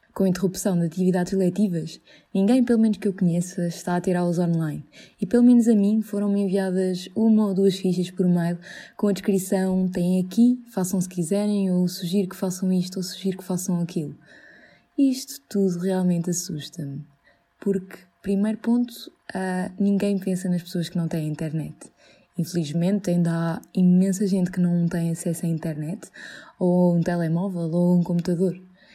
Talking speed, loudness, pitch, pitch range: 165 wpm, -23 LUFS, 185 Hz, 175-200 Hz